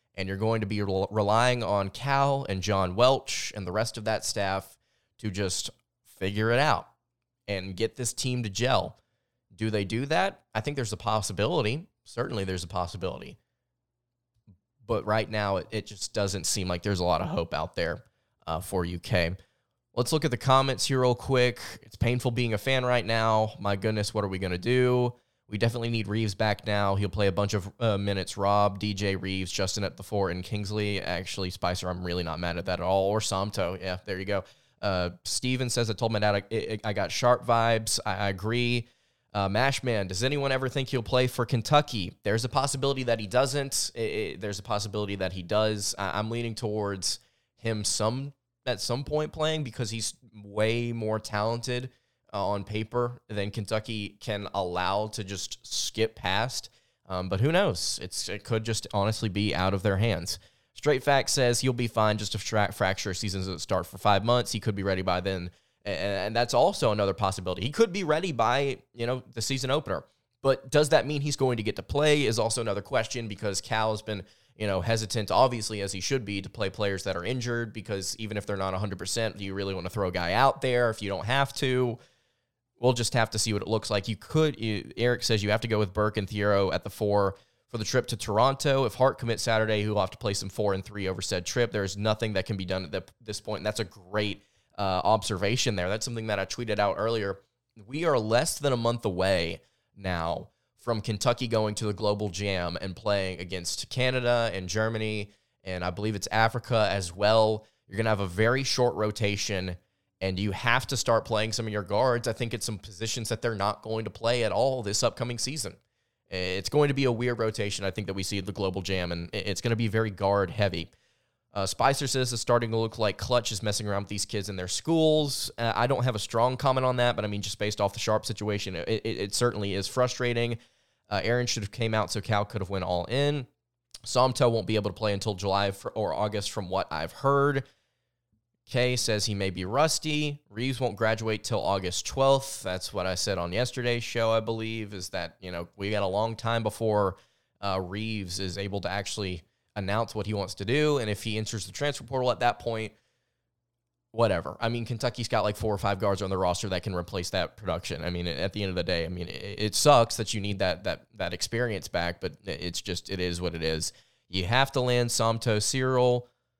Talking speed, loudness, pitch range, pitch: 220 wpm, -28 LUFS, 100-120 Hz, 110 Hz